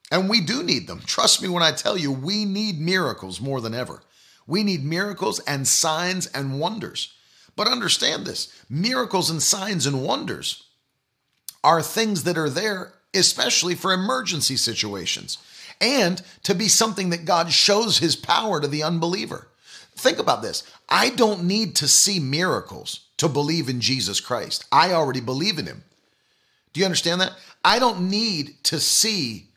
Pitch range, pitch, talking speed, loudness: 145-195 Hz, 170 Hz, 165 wpm, -21 LUFS